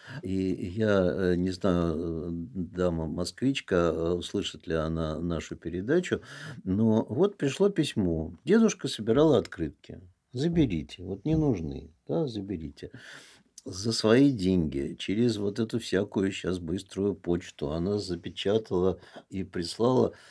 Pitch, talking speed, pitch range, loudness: 95 Hz, 110 wpm, 85-115 Hz, -28 LUFS